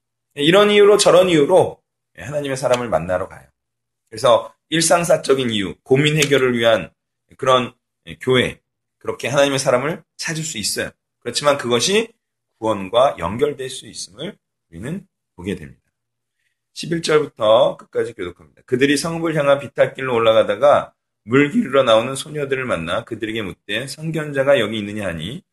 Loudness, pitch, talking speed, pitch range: -18 LUFS, 135 Hz, 335 characters per minute, 115-155 Hz